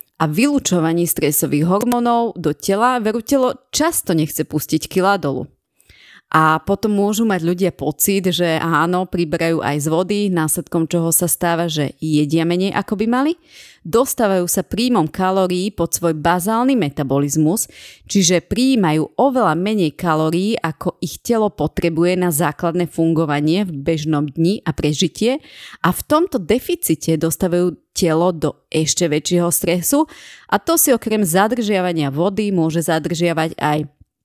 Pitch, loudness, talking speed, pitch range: 175 Hz, -17 LUFS, 135 wpm, 160-205 Hz